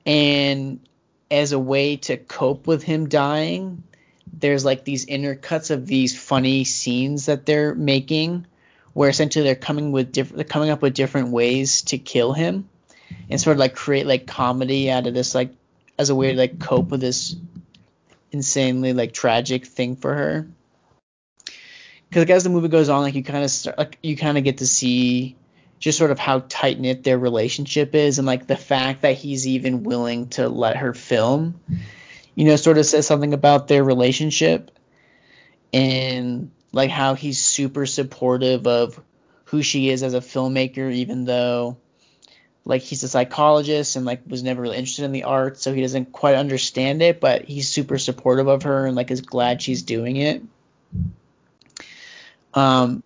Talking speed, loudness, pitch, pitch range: 180 wpm, -20 LUFS, 135 Hz, 130-150 Hz